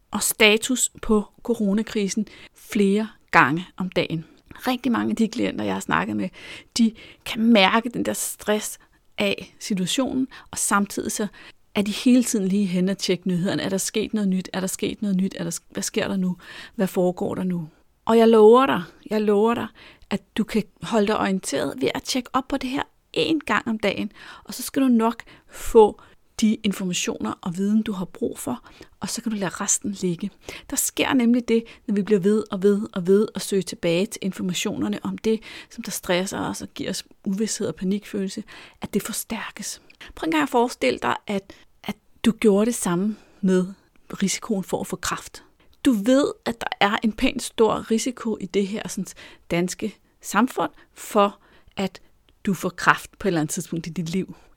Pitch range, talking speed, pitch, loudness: 190-225 Hz, 195 wpm, 205 Hz, -23 LUFS